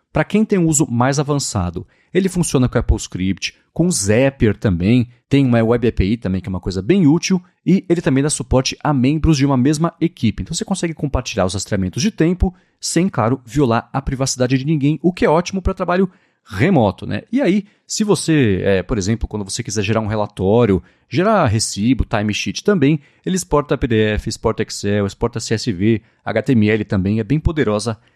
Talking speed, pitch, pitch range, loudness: 190 wpm, 125 Hz, 105-160 Hz, -17 LUFS